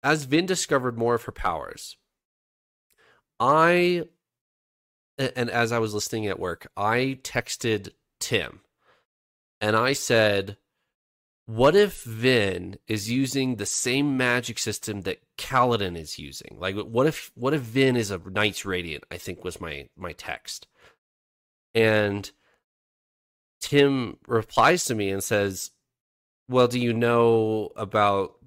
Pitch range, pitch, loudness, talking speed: 100-130 Hz, 110 Hz, -24 LUFS, 130 wpm